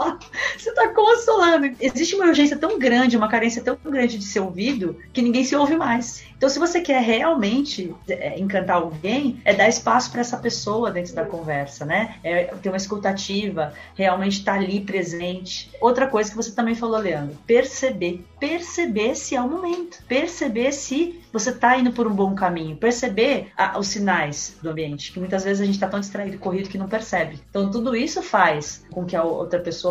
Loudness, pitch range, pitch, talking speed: -21 LUFS, 190-260 Hz, 220 Hz, 190 wpm